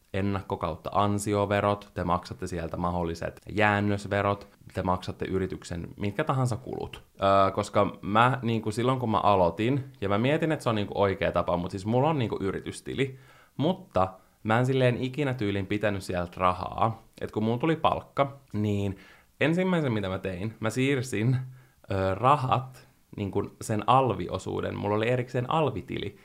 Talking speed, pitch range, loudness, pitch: 160 wpm, 95-125 Hz, -28 LUFS, 105 Hz